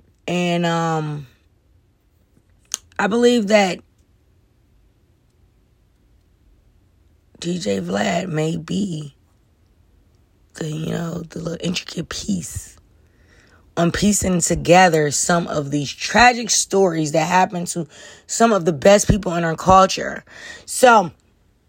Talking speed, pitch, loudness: 100 wpm, 155 Hz, -18 LUFS